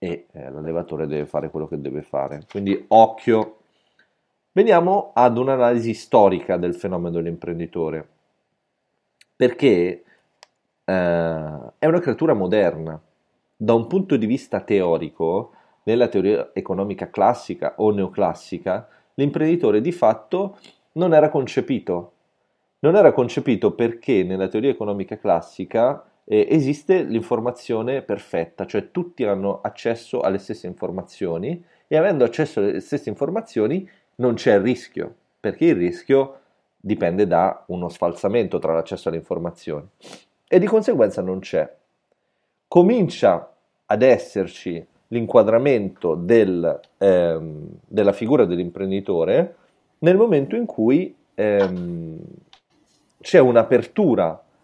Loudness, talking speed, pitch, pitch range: -20 LUFS, 110 wpm, 105 Hz, 85-135 Hz